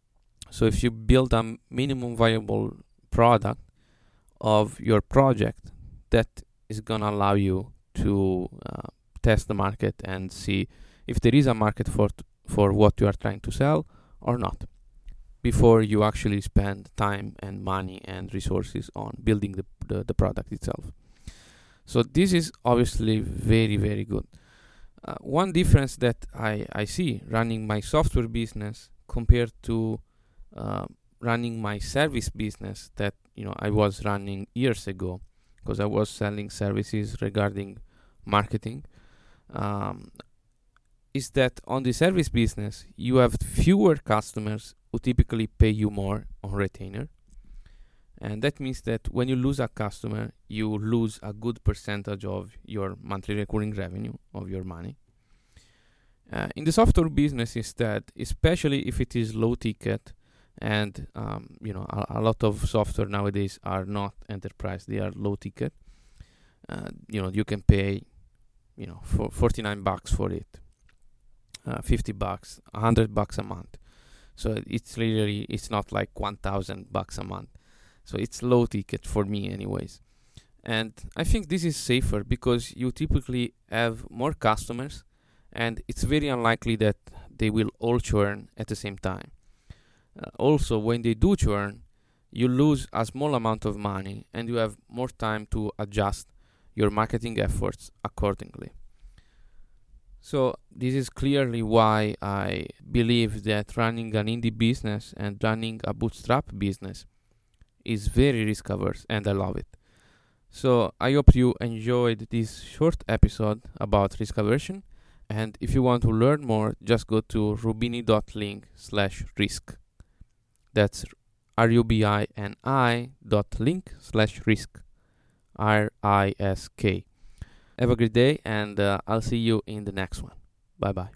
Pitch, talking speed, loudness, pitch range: 110 Hz, 145 wpm, -26 LUFS, 100-120 Hz